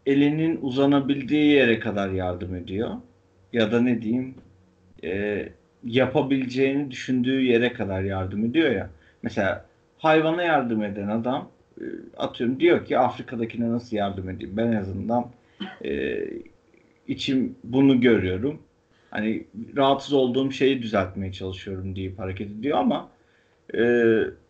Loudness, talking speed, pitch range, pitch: -24 LUFS, 120 wpm, 100-135 Hz, 120 Hz